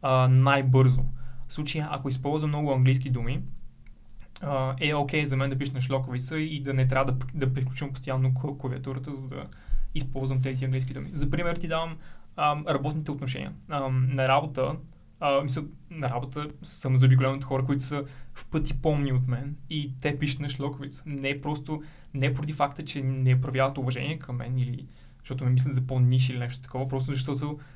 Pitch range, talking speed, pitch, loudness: 130-145 Hz, 185 wpm, 135 Hz, -28 LUFS